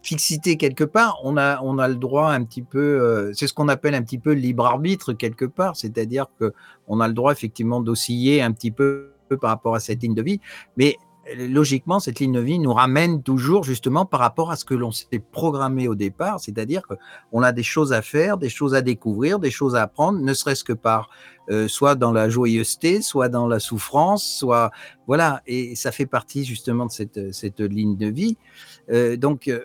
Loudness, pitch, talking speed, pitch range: -21 LUFS, 130 Hz, 215 wpm, 115-145 Hz